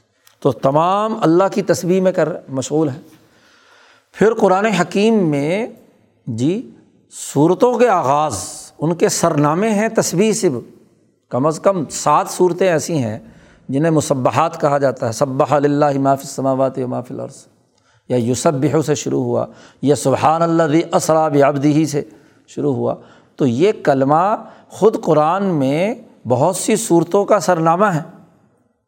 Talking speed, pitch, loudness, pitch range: 150 wpm, 160 Hz, -16 LUFS, 140-195 Hz